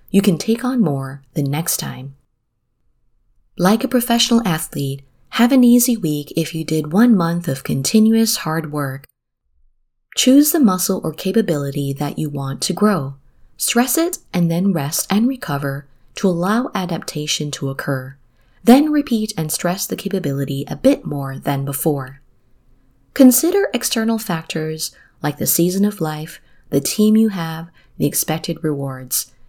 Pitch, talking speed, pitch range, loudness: 160 Hz, 150 wpm, 140-210 Hz, -18 LUFS